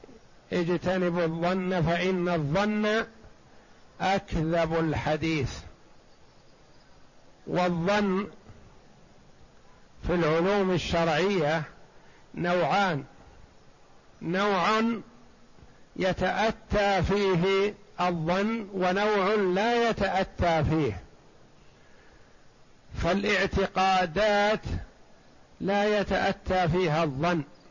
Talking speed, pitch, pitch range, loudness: 50 wpm, 185 Hz, 170-200 Hz, -27 LUFS